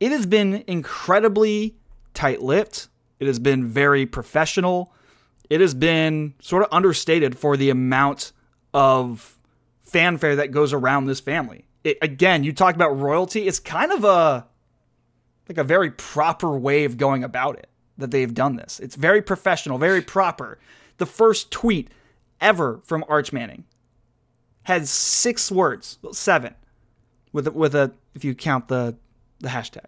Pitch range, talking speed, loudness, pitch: 130-175 Hz, 150 wpm, -20 LUFS, 145 Hz